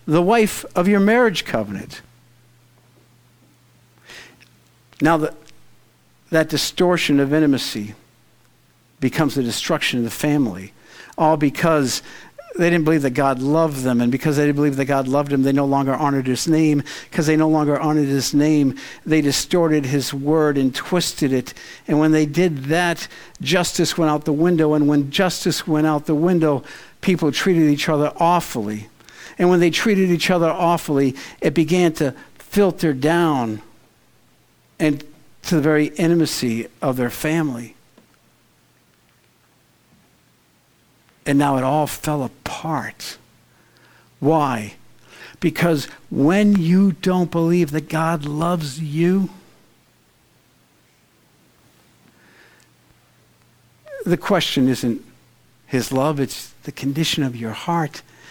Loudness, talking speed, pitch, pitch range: -19 LUFS, 130 wpm, 150 Hz, 135-170 Hz